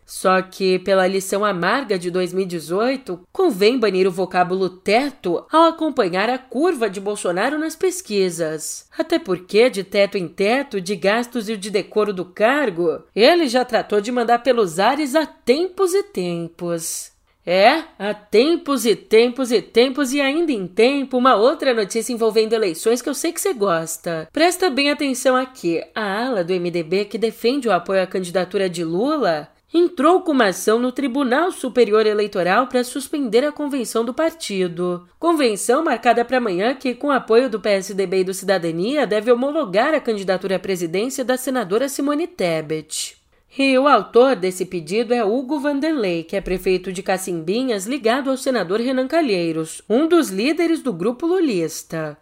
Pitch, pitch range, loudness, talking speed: 225 Hz, 190-275 Hz, -19 LUFS, 165 wpm